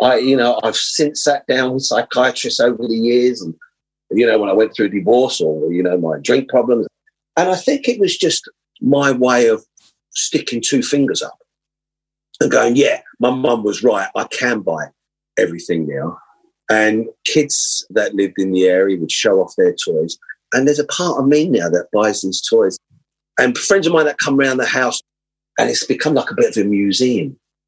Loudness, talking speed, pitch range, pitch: -16 LUFS, 200 wpm, 110-155 Hz, 130 Hz